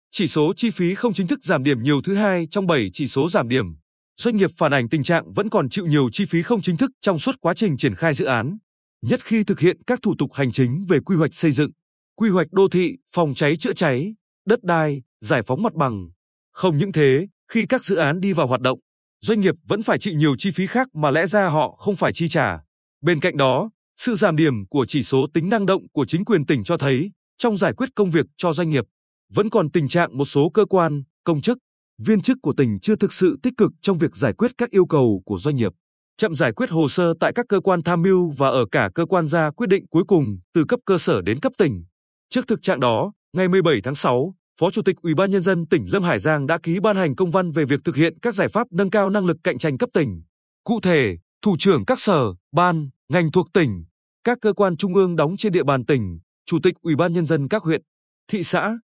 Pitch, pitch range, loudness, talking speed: 170 Hz, 145-200 Hz, -20 LUFS, 255 wpm